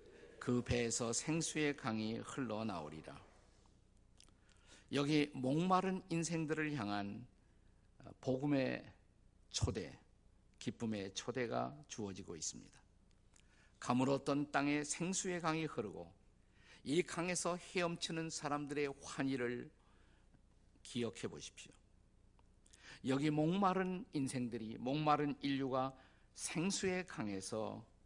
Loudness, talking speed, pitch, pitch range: -40 LUFS, 220 characters per minute, 125 Hz, 100-150 Hz